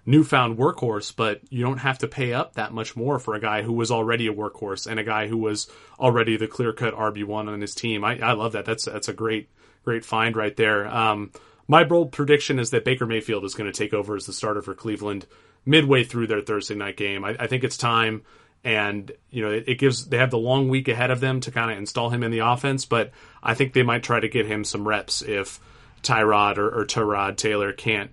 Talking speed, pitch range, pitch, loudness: 245 wpm, 105-125 Hz, 115 Hz, -23 LUFS